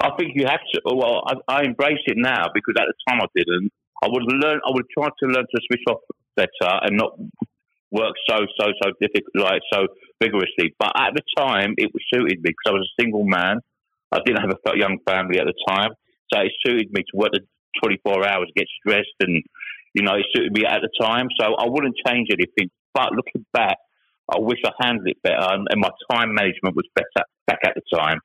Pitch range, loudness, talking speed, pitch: 100-135 Hz, -21 LUFS, 225 wpm, 125 Hz